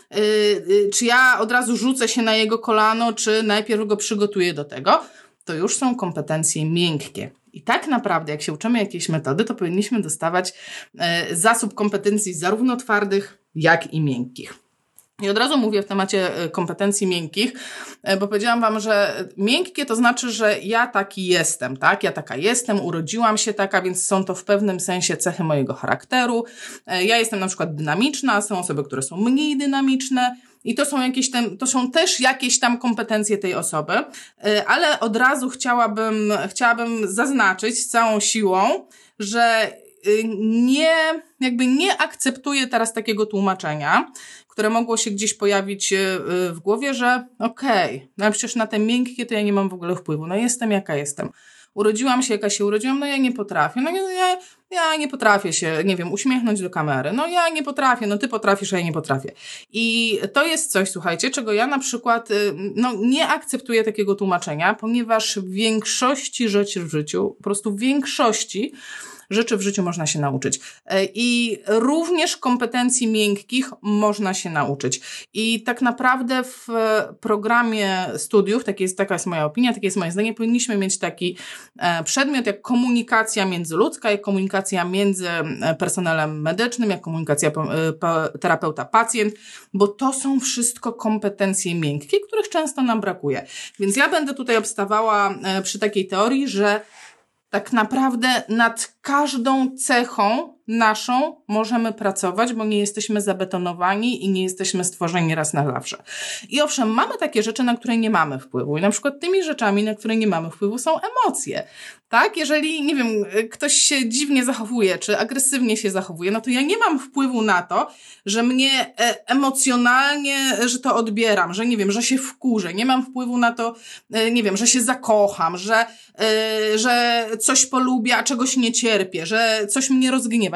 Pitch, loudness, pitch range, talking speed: 220 Hz, -20 LUFS, 195-250 Hz, 165 wpm